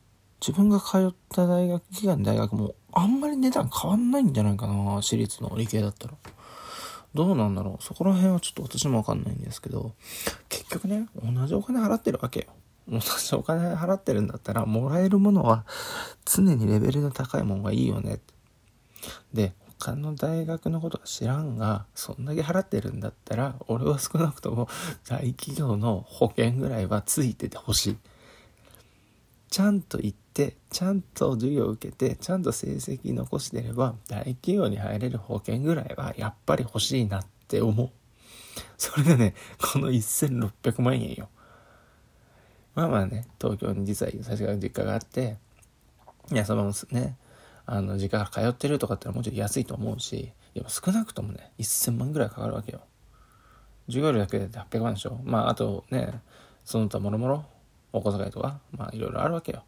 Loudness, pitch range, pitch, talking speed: -27 LUFS, 105-150 Hz, 120 Hz, 340 characters per minute